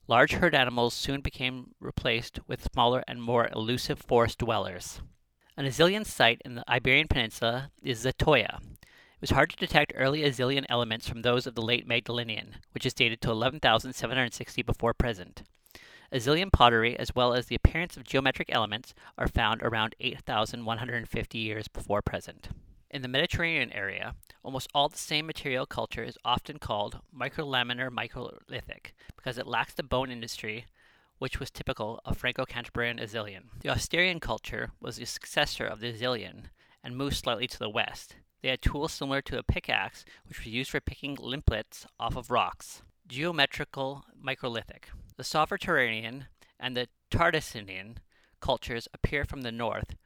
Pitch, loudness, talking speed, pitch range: 125 Hz, -29 LUFS, 155 wpm, 115-135 Hz